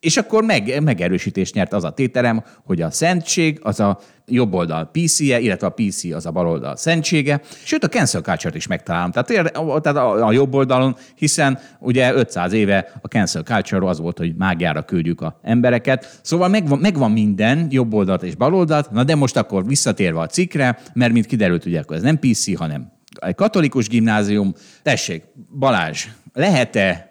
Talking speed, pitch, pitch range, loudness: 170 wpm, 125 Hz, 100-150 Hz, -18 LUFS